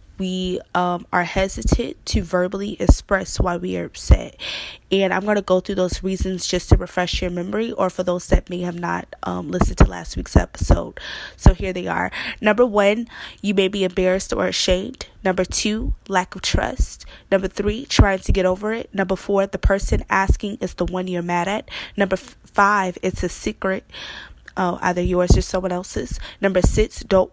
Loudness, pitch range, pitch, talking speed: -21 LUFS, 180-200 Hz, 190 Hz, 190 wpm